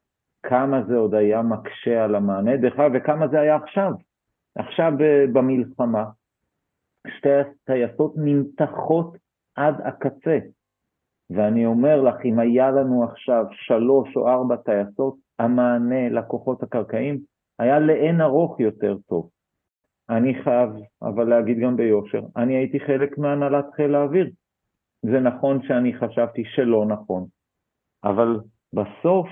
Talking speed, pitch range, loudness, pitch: 120 wpm, 115-140 Hz, -21 LUFS, 125 Hz